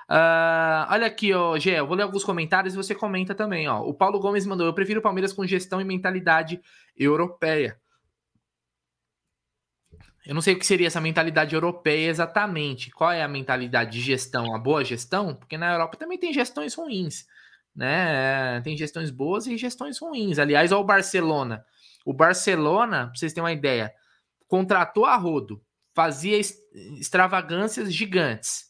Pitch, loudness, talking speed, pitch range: 170 Hz, -24 LUFS, 160 wpm, 150-195 Hz